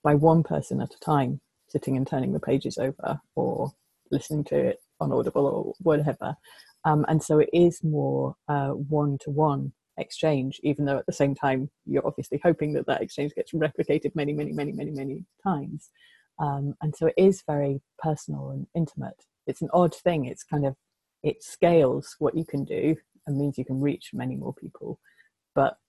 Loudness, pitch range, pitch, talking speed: -27 LUFS, 140-160 Hz, 150 Hz, 195 wpm